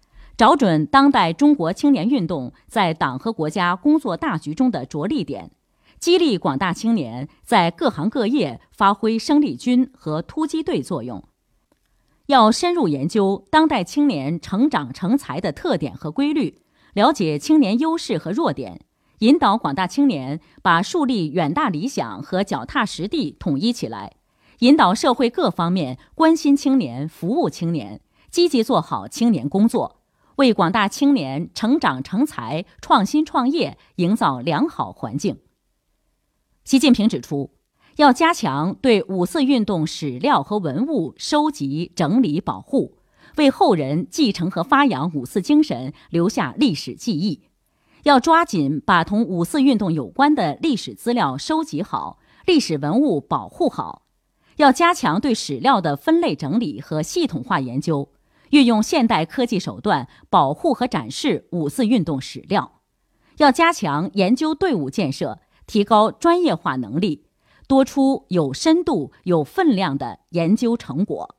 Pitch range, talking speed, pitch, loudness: 170-285 Hz, 230 characters per minute, 230 Hz, -19 LUFS